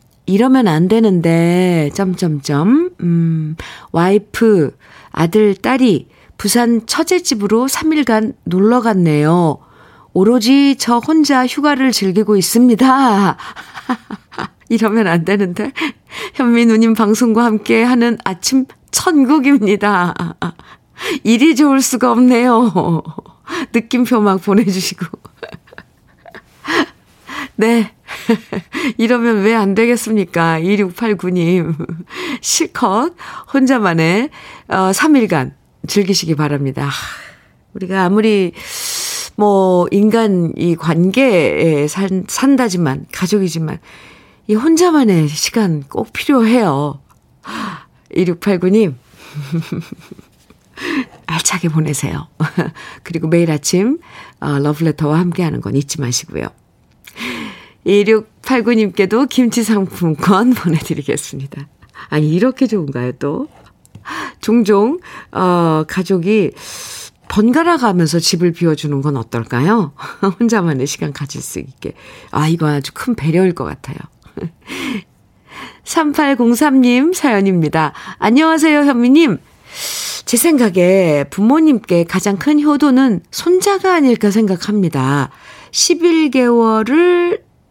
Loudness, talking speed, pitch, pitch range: -14 LUFS, 205 characters per minute, 205 Hz, 170-250 Hz